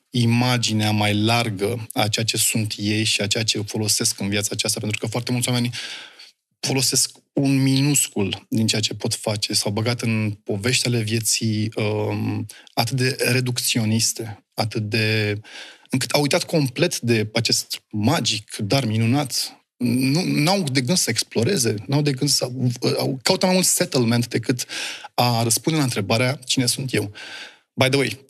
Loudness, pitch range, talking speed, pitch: -21 LUFS, 110-130 Hz, 160 wpm, 120 Hz